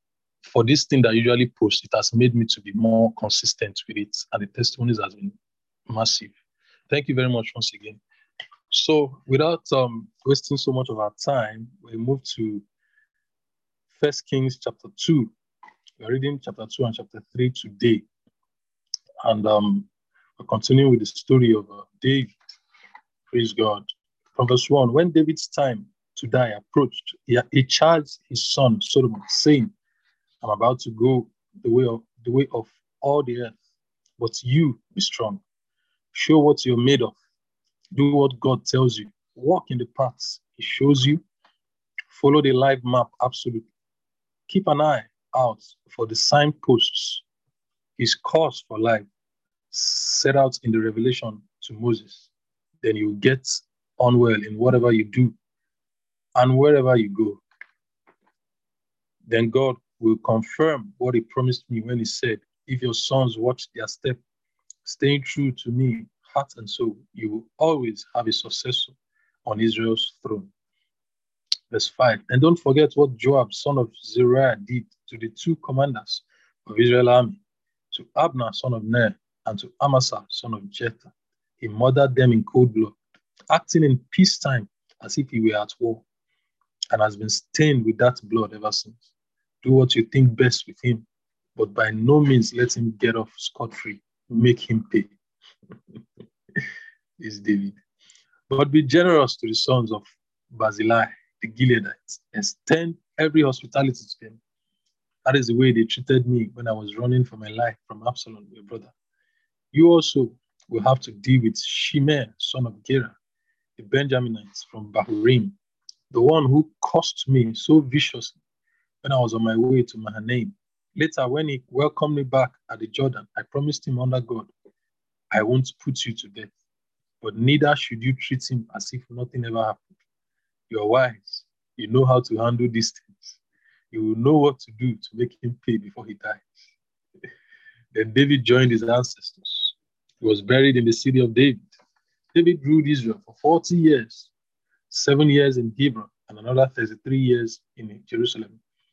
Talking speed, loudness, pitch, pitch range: 165 wpm, -21 LUFS, 125 Hz, 115-140 Hz